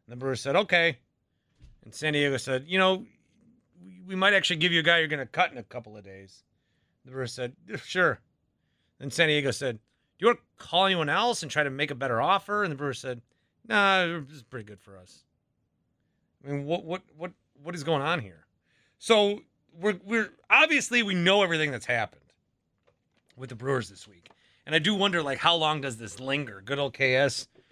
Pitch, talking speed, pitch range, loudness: 150 Hz, 210 wpm, 130-185 Hz, -26 LUFS